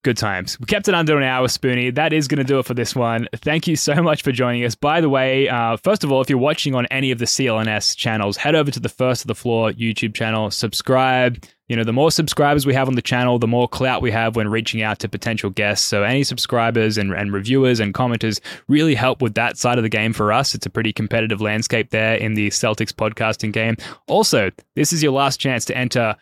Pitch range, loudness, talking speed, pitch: 110-135 Hz, -18 LUFS, 250 wpm, 120 Hz